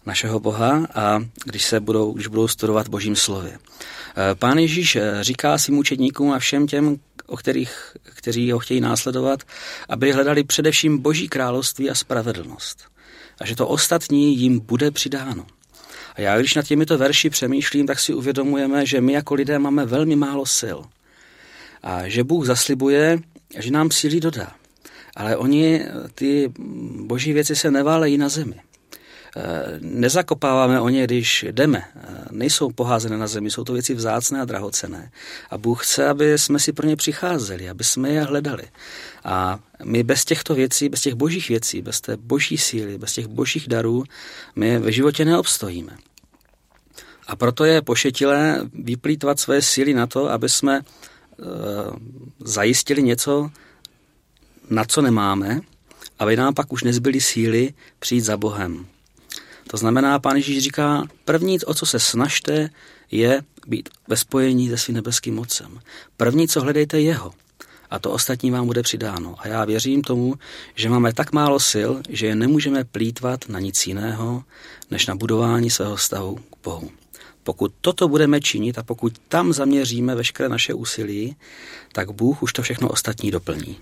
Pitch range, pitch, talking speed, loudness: 115-145 Hz, 130 Hz, 155 wpm, -20 LUFS